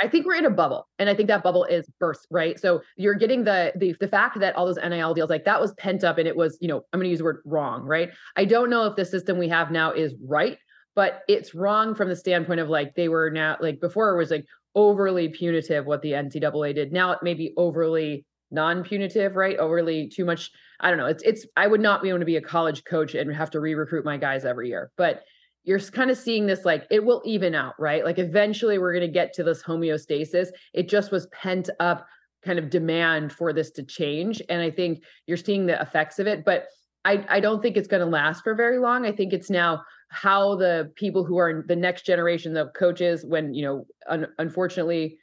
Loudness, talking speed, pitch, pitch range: -24 LUFS, 240 wpm, 175 Hz, 160-195 Hz